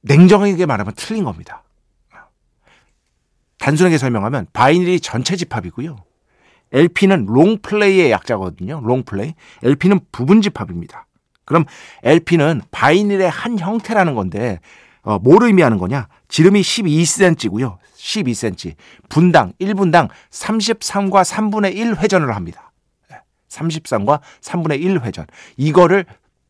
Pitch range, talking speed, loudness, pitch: 120-195 Hz, 255 characters per minute, -15 LUFS, 165 Hz